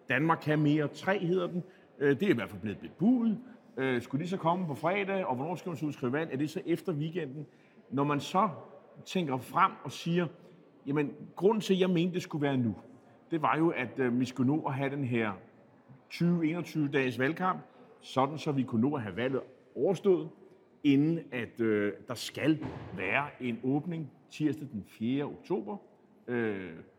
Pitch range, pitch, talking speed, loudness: 130-175 Hz, 150 Hz, 185 wpm, -32 LUFS